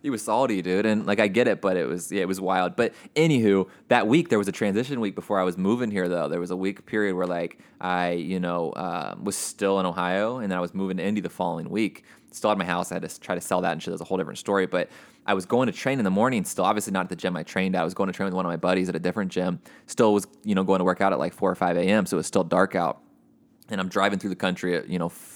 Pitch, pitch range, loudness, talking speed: 95 Hz, 90-95 Hz, -25 LUFS, 320 wpm